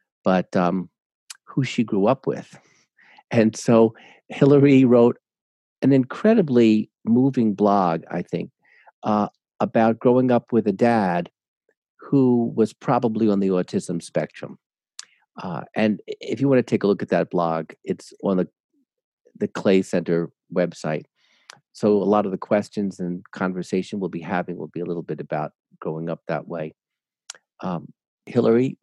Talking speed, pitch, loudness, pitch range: 150 wpm, 110 Hz, -22 LUFS, 95-125 Hz